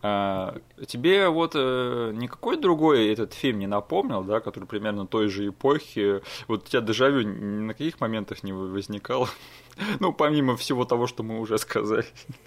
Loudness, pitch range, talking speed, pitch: -26 LUFS, 100-130 Hz, 170 wpm, 110 Hz